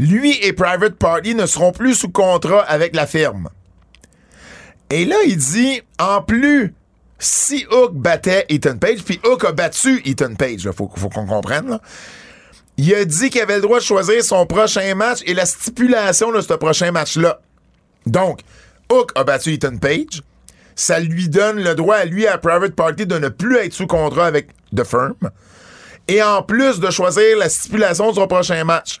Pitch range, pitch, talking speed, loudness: 155-220 Hz, 185 Hz, 190 wpm, -15 LUFS